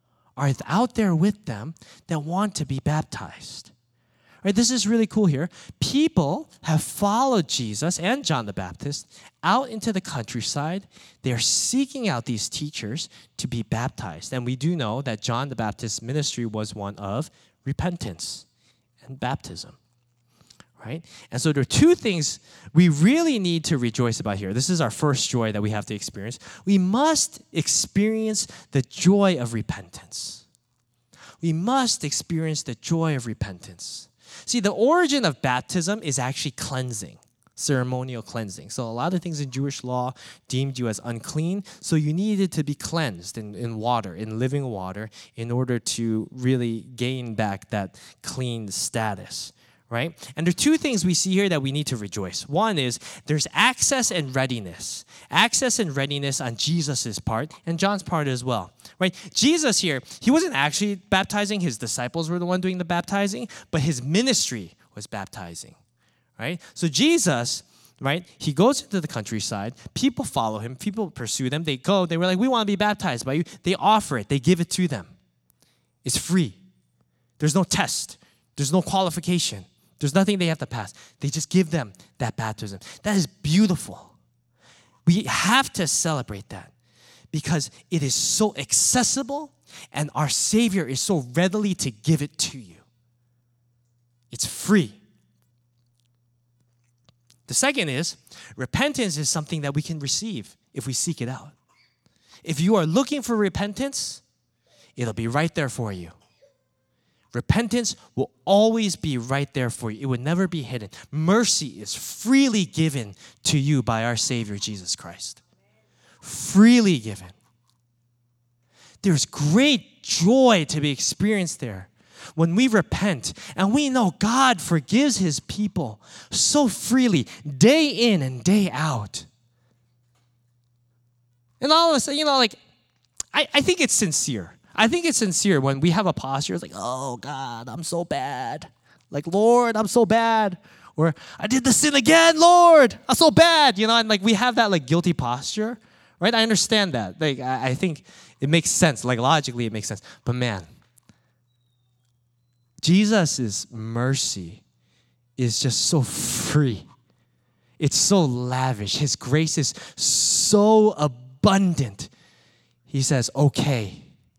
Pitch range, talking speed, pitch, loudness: 120-190 Hz, 155 wpm, 145 Hz, -22 LUFS